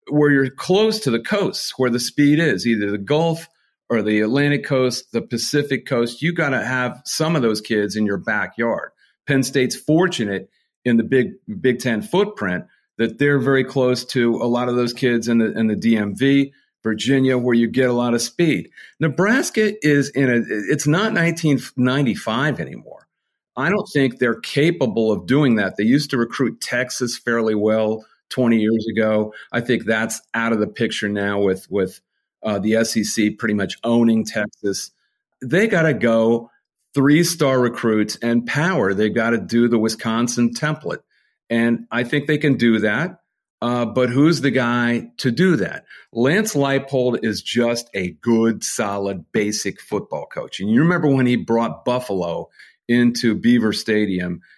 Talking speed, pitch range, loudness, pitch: 175 wpm, 115-140 Hz, -19 LUFS, 120 Hz